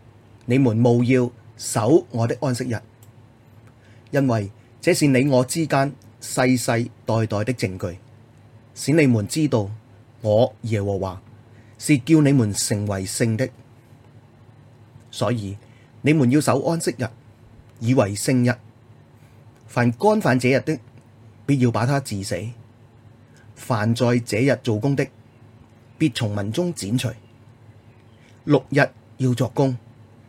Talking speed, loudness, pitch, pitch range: 170 characters per minute, -21 LUFS, 120 Hz, 115-130 Hz